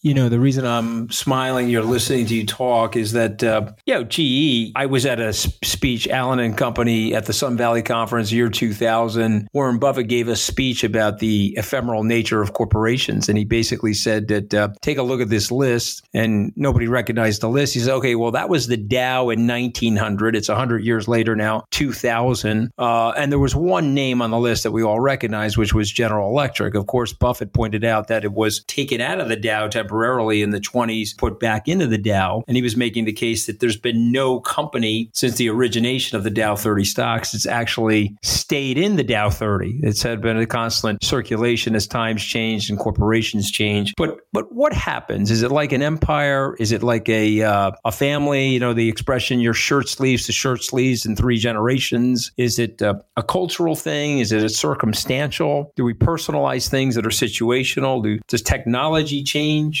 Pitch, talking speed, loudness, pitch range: 115 Hz, 205 wpm, -19 LUFS, 110-130 Hz